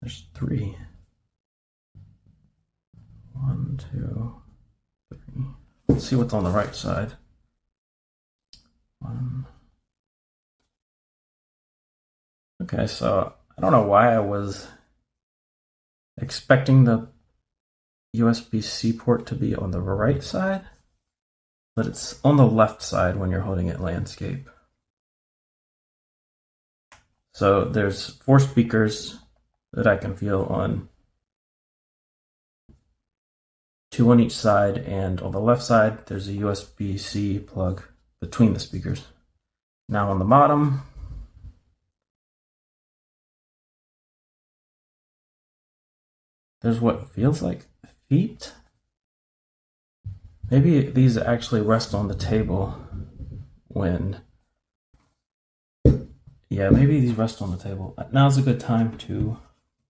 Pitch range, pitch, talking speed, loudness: 95-120 Hz, 105 Hz, 100 wpm, -23 LUFS